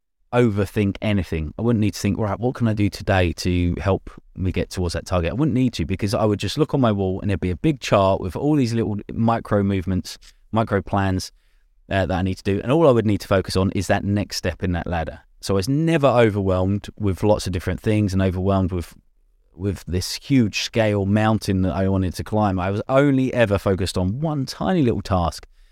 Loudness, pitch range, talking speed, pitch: -21 LUFS, 95-110 Hz, 235 wpm, 100 Hz